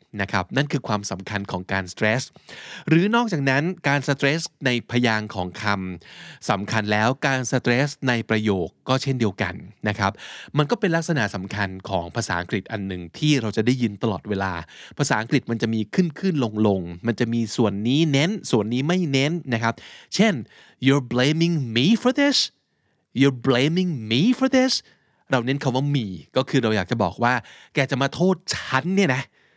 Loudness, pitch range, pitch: -22 LUFS, 105-145 Hz, 125 Hz